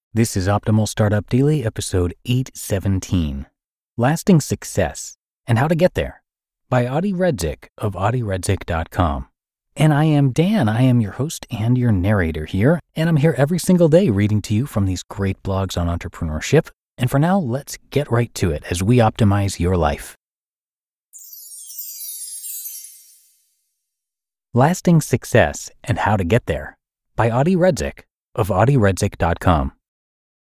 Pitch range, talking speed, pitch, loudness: 95-135 Hz, 140 wpm, 110 Hz, -19 LUFS